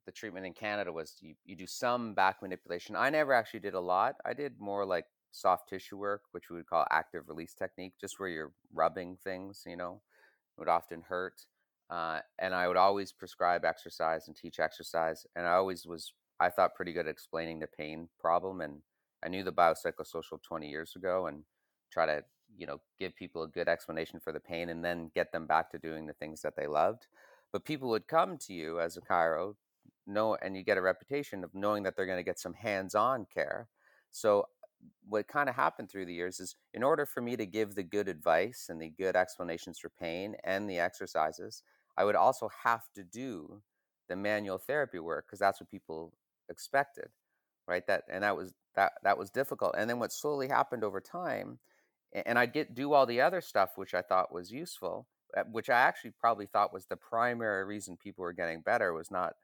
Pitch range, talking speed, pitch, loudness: 85-110 Hz, 210 wpm, 95 Hz, -34 LUFS